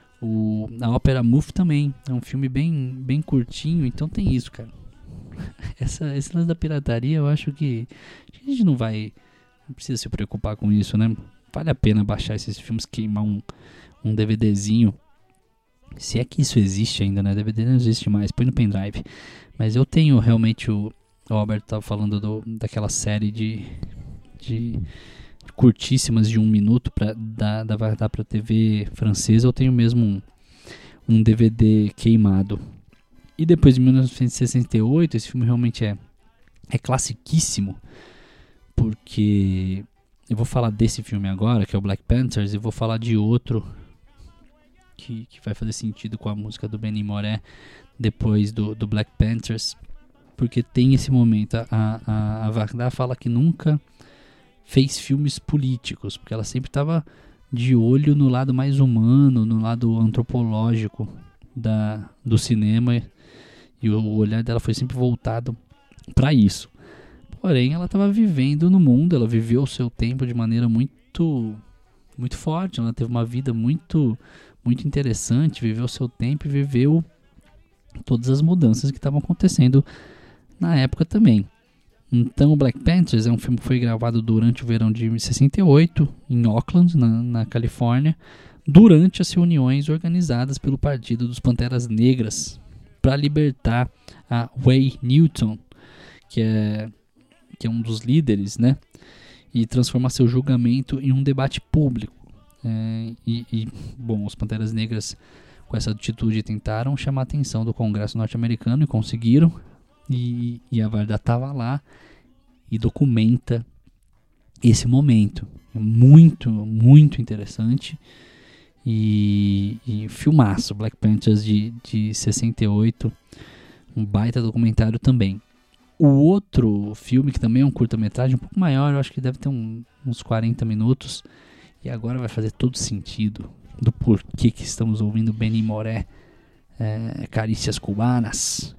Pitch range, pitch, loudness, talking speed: 110-130 Hz, 115 Hz, -20 LUFS, 145 wpm